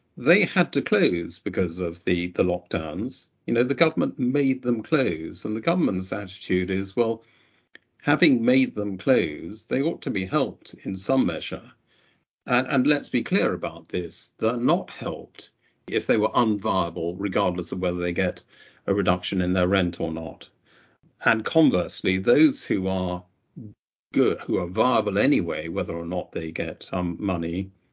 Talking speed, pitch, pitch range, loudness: 170 wpm, 95 Hz, 90-110 Hz, -24 LUFS